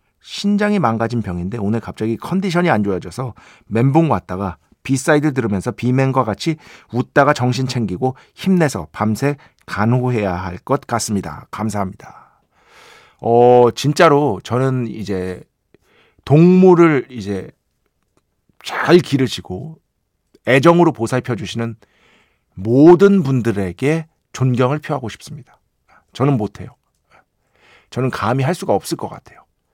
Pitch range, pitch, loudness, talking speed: 105-145 Hz, 125 Hz, -16 LUFS, 265 characters per minute